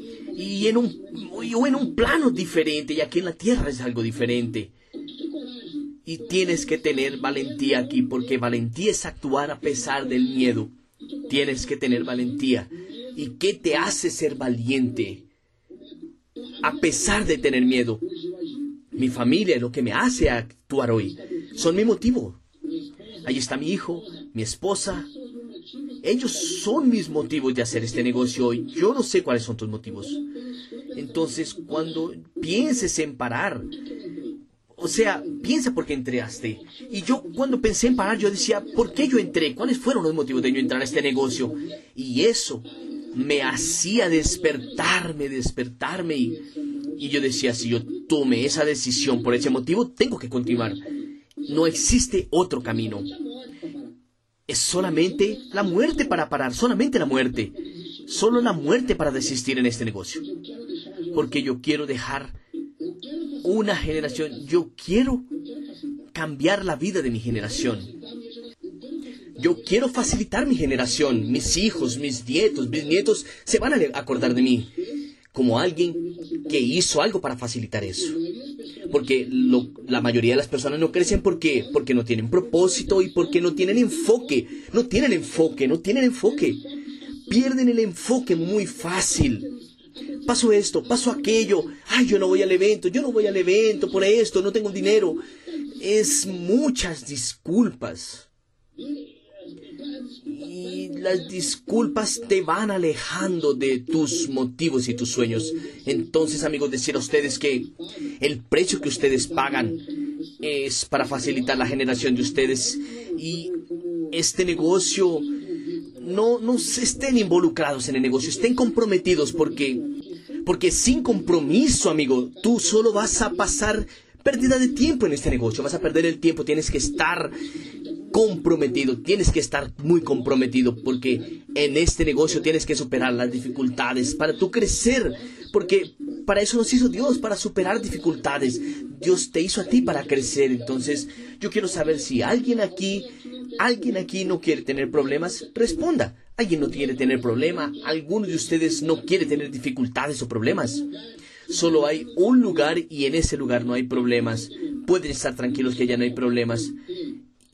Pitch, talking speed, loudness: 200 Hz, 150 wpm, -23 LUFS